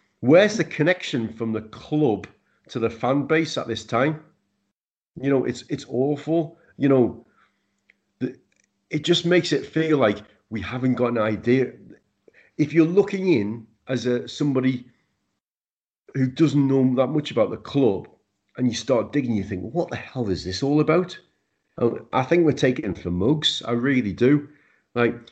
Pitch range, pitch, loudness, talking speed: 115-150 Hz, 130 Hz, -23 LUFS, 170 wpm